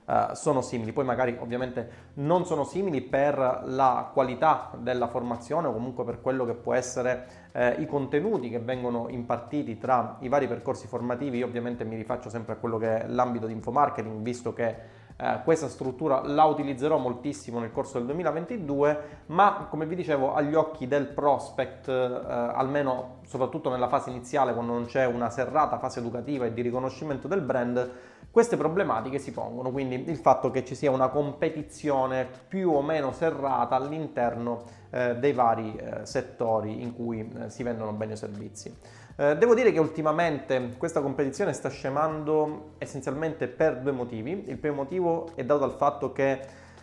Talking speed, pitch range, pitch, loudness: 170 wpm, 120-145 Hz, 130 Hz, -28 LUFS